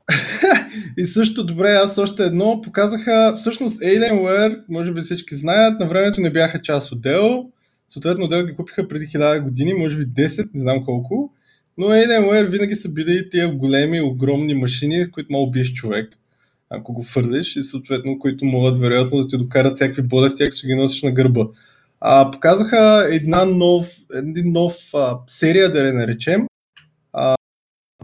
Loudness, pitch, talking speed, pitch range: -17 LUFS, 160 Hz, 165 wpm, 135-195 Hz